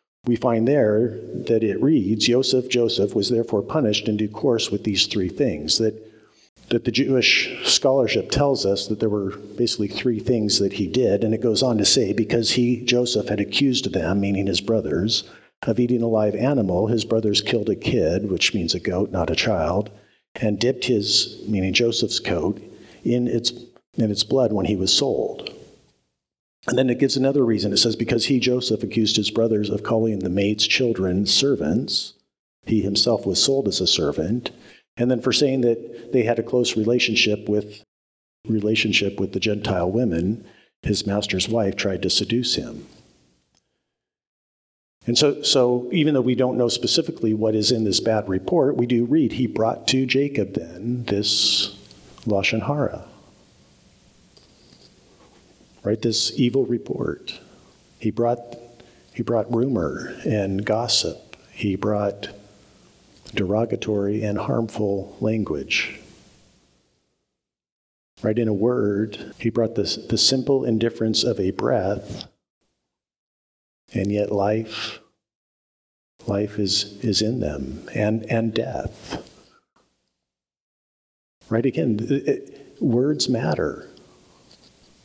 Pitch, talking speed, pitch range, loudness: 110 Hz, 145 wpm, 100-120 Hz, -21 LUFS